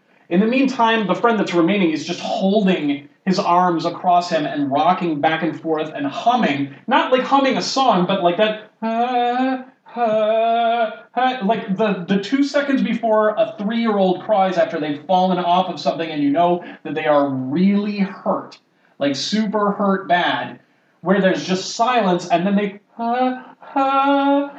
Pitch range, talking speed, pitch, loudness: 175-235 Hz, 170 wpm, 200 Hz, -19 LUFS